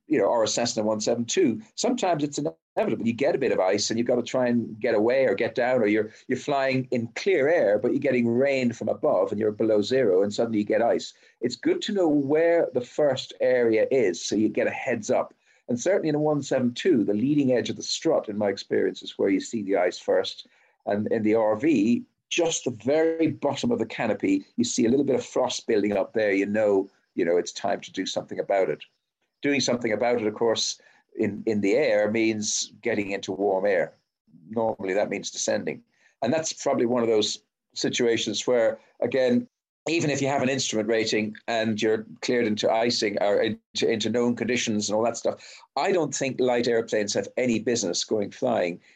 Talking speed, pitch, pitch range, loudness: 215 wpm, 120 Hz, 110-150 Hz, -25 LUFS